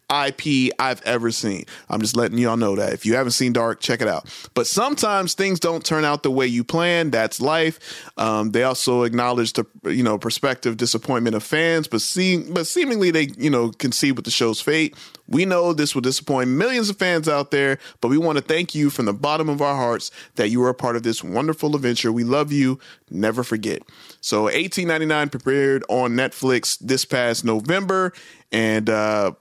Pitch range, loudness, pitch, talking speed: 120-155 Hz, -20 LUFS, 135 Hz, 200 wpm